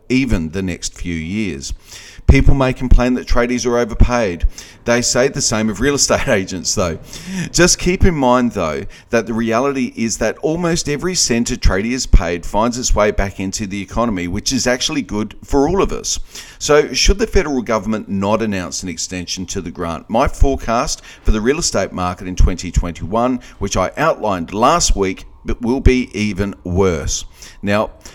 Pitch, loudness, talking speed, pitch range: 110 Hz, -17 LUFS, 180 wpm, 95-125 Hz